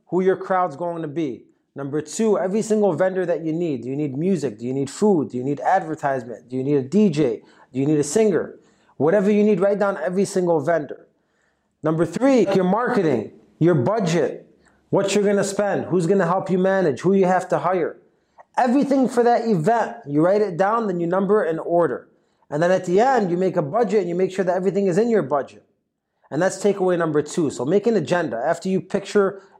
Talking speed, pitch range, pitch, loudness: 225 wpm, 160-205 Hz, 185 Hz, -21 LUFS